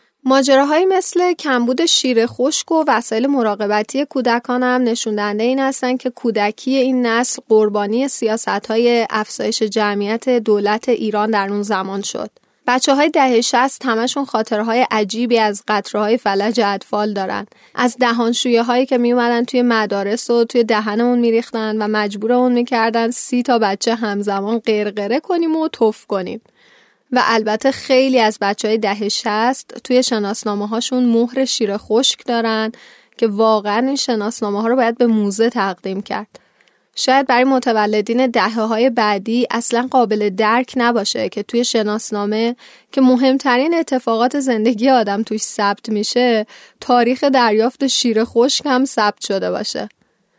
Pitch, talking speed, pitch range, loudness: 235 Hz, 140 wpm, 215-255 Hz, -16 LUFS